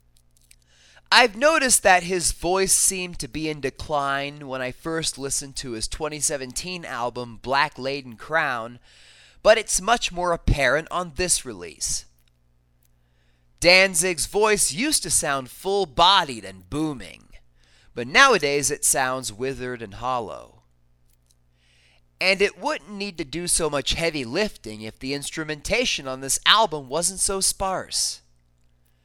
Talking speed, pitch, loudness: 130 wpm, 140 Hz, -21 LUFS